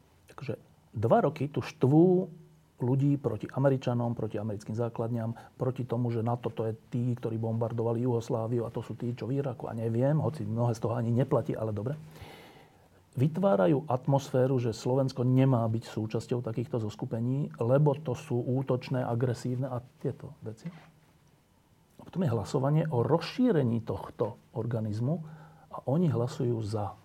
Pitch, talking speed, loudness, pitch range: 125 Hz, 150 wpm, -30 LUFS, 115-140 Hz